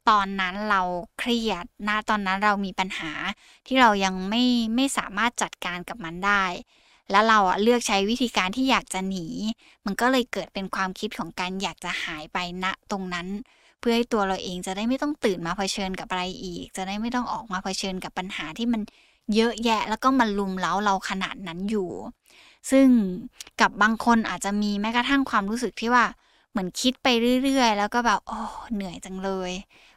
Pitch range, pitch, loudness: 190-235 Hz, 205 Hz, -25 LUFS